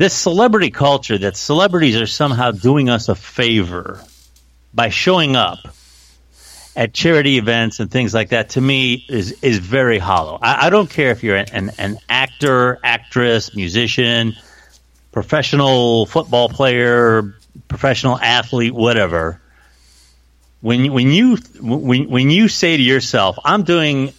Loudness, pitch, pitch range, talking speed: -15 LUFS, 120 Hz, 100-135 Hz, 140 wpm